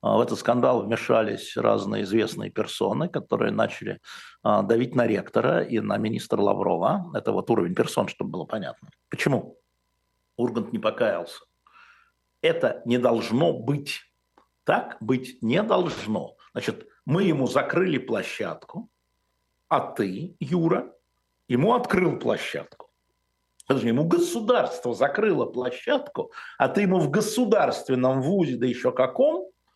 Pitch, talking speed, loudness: 130 Hz, 120 wpm, -25 LUFS